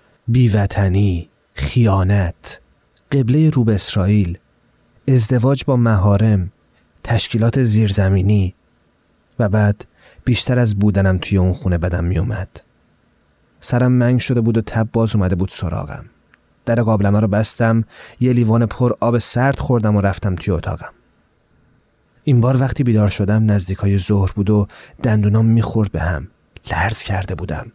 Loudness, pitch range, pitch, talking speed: -17 LUFS, 95-120 Hz, 105 Hz, 130 wpm